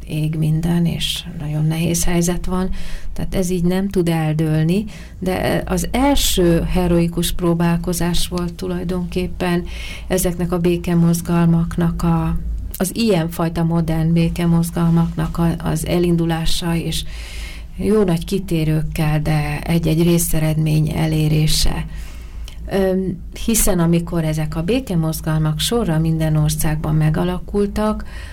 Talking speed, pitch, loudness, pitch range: 100 wpm, 170 Hz, -18 LUFS, 160-180 Hz